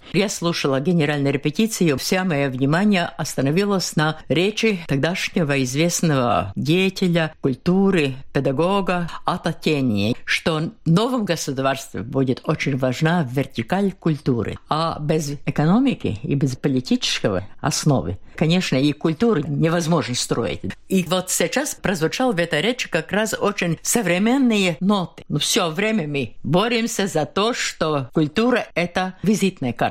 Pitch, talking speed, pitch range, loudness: 170 Hz, 125 wpm, 145-190 Hz, -20 LUFS